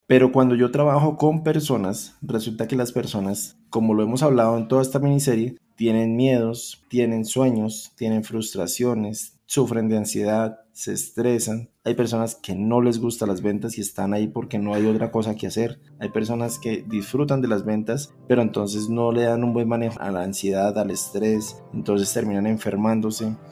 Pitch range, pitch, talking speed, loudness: 110-120 Hz, 115 Hz, 180 wpm, -23 LUFS